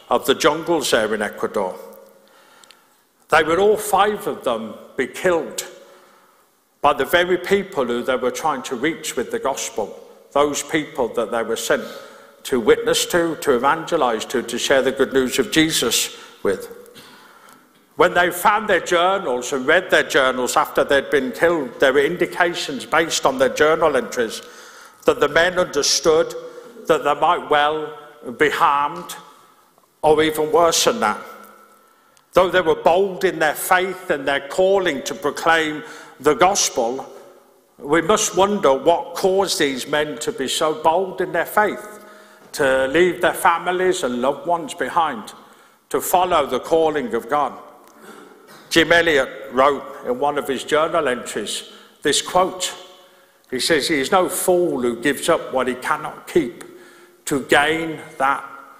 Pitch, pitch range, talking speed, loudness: 175 Hz, 150-250 Hz, 155 wpm, -19 LUFS